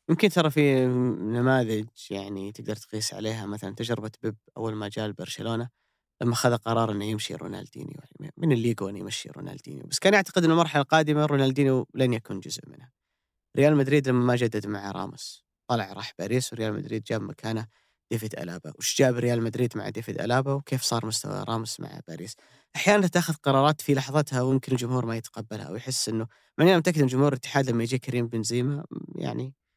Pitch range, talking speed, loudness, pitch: 110-145 Hz, 175 wpm, -26 LUFS, 125 Hz